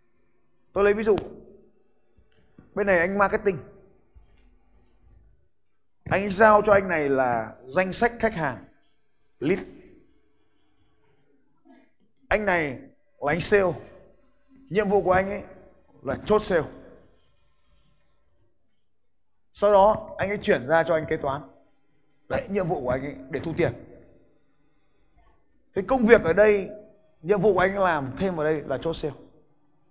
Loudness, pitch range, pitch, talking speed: -23 LUFS, 145-205 Hz, 180 Hz, 135 wpm